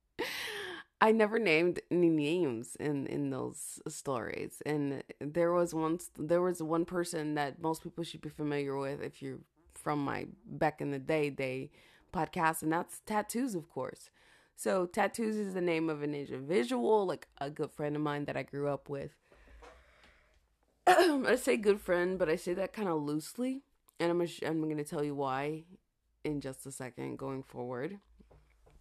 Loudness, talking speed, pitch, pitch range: -34 LUFS, 175 wpm, 160 Hz, 145-180 Hz